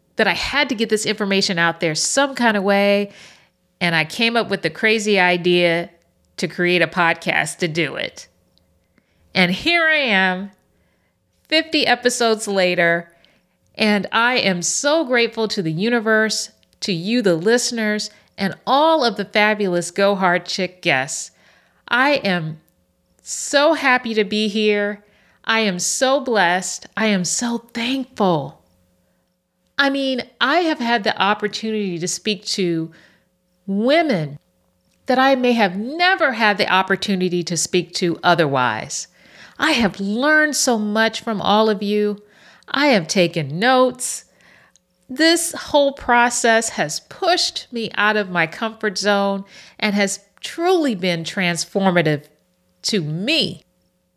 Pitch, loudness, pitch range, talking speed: 205 Hz, -18 LUFS, 175-235 Hz, 140 wpm